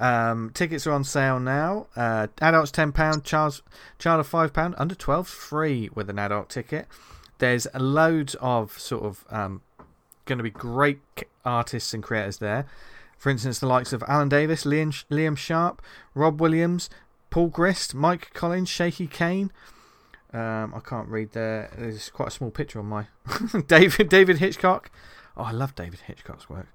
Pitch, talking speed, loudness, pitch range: 140 Hz, 170 wpm, -24 LUFS, 115-160 Hz